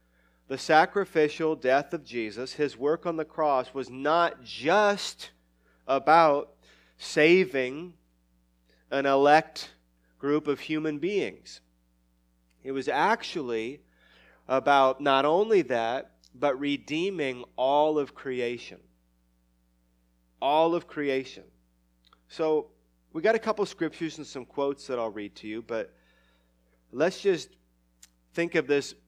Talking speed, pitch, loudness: 120 wpm, 130 Hz, -27 LUFS